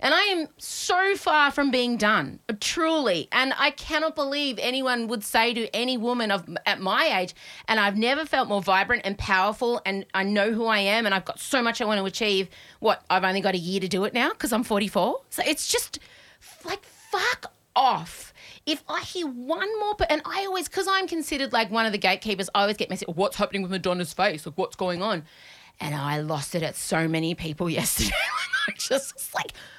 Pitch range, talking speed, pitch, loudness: 190-290 Hz, 215 wpm, 220 Hz, -25 LUFS